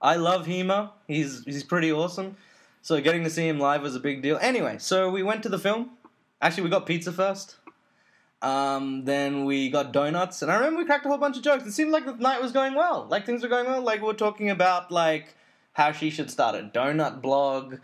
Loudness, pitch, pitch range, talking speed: -25 LUFS, 180 Hz, 150-220 Hz, 235 wpm